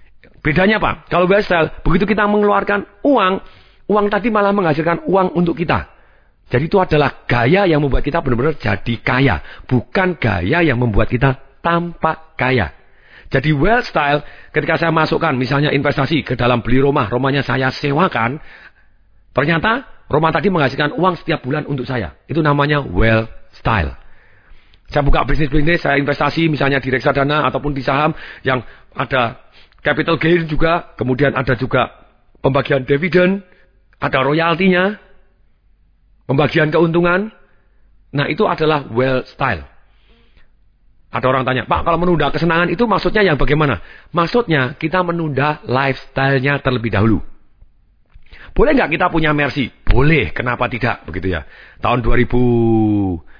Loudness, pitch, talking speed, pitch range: -16 LUFS, 140 Hz, 135 wpm, 120-165 Hz